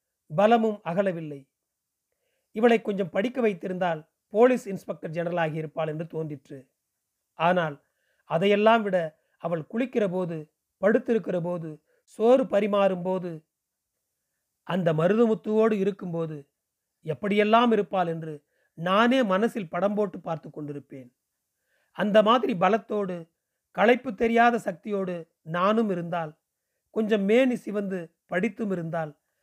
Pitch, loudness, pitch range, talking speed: 190 Hz, -25 LUFS, 165-220 Hz, 100 wpm